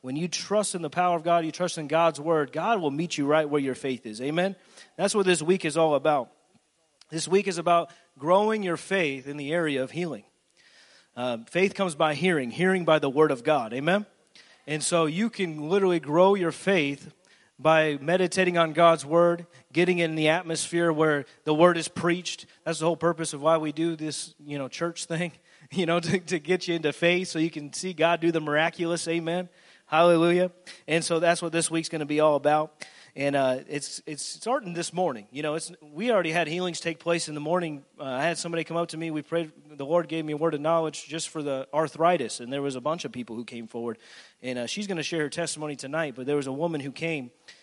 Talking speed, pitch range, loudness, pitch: 235 wpm, 150-175 Hz, -26 LUFS, 165 Hz